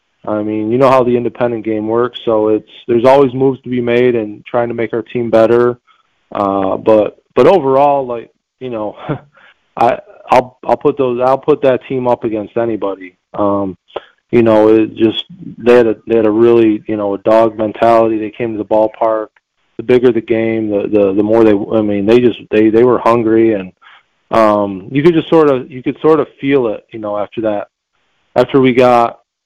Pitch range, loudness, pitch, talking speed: 110-125 Hz, -12 LUFS, 115 Hz, 210 wpm